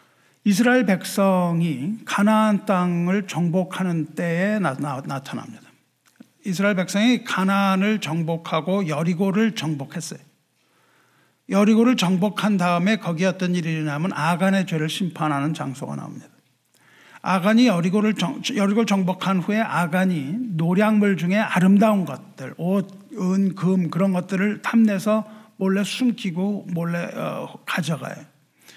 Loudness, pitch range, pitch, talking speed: -21 LUFS, 170-210 Hz, 190 Hz, 290 characters per minute